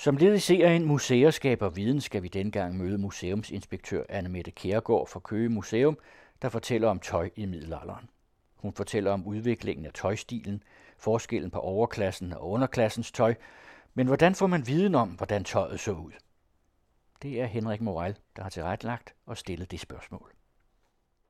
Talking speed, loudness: 160 wpm, -29 LUFS